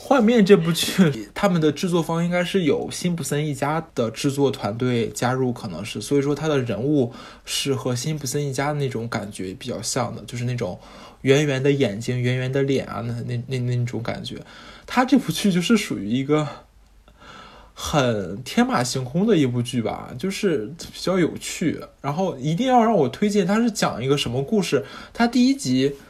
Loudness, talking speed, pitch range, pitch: -22 LUFS, 280 characters per minute, 125-180 Hz, 140 Hz